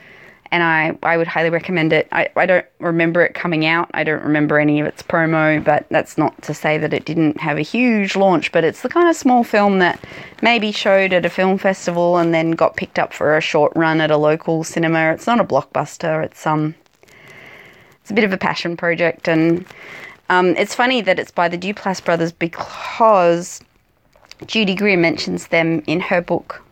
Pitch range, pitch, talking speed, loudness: 160-190 Hz, 170 Hz, 205 wpm, -17 LUFS